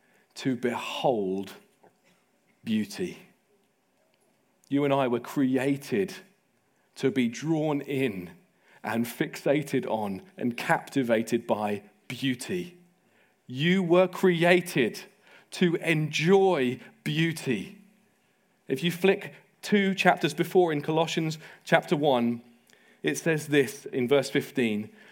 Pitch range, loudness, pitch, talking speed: 130-185 Hz, -27 LUFS, 155 Hz, 100 wpm